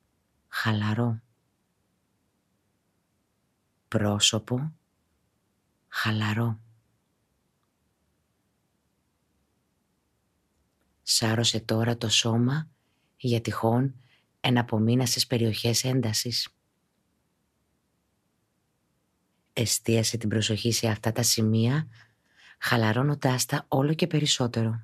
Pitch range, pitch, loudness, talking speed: 110-125 Hz, 115 Hz, -26 LUFS, 60 wpm